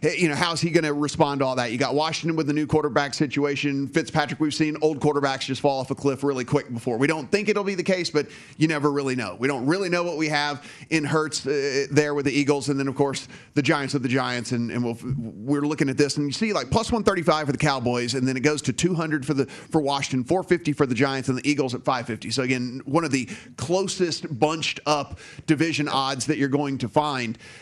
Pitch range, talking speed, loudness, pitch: 135-155 Hz, 260 wpm, -24 LUFS, 145 Hz